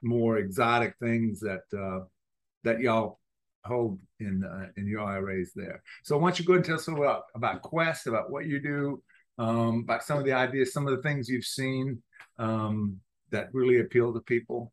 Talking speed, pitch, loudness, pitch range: 205 wpm, 120 Hz, -29 LUFS, 105-135 Hz